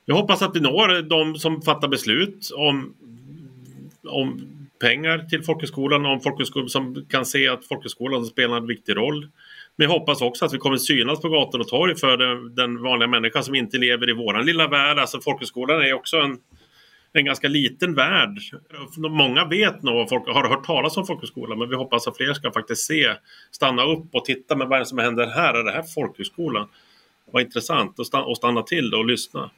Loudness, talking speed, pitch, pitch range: -21 LUFS, 195 wpm, 135 Hz, 125-155 Hz